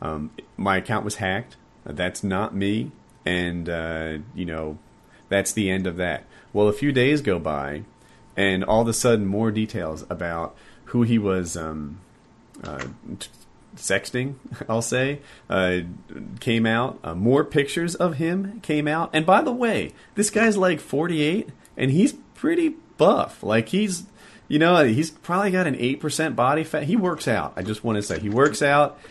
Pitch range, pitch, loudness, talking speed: 95-155 Hz, 115 Hz, -23 LUFS, 170 wpm